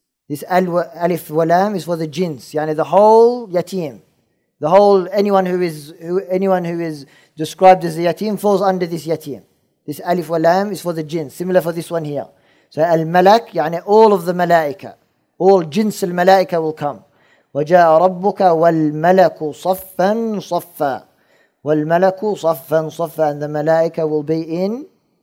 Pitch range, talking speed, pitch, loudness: 160-190 Hz, 170 wpm, 170 Hz, -16 LUFS